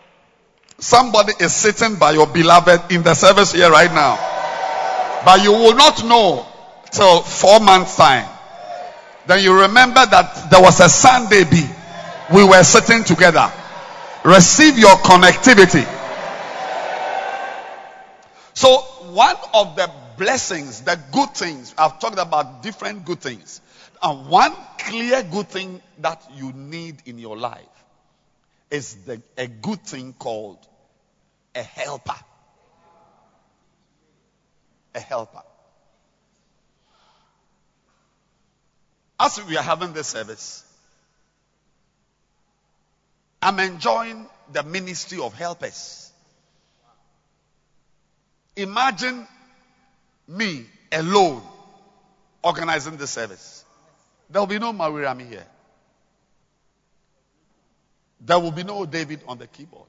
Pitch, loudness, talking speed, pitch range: 180 Hz, -13 LUFS, 105 wpm, 155-205 Hz